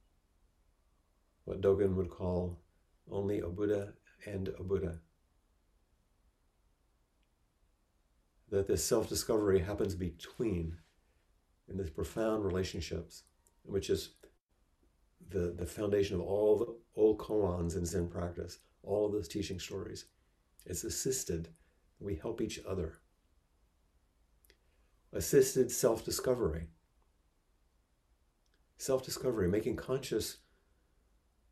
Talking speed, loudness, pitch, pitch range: 90 wpm, -35 LUFS, 85 Hz, 75-95 Hz